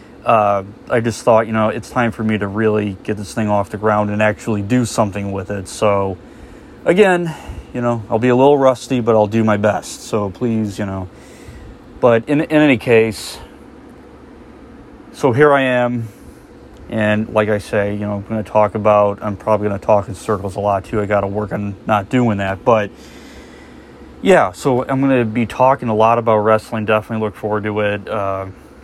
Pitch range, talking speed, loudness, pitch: 105-120 Hz, 195 wpm, -16 LUFS, 110 Hz